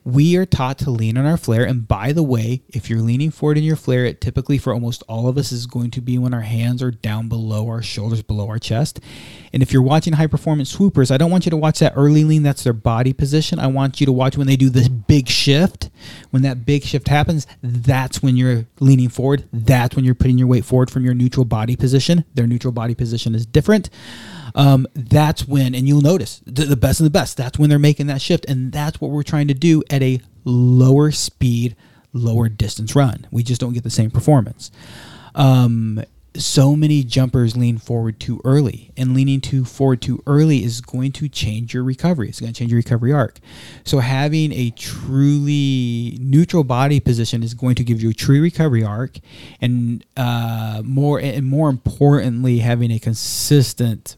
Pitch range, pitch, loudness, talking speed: 120-145 Hz, 130 Hz, -17 LUFS, 210 wpm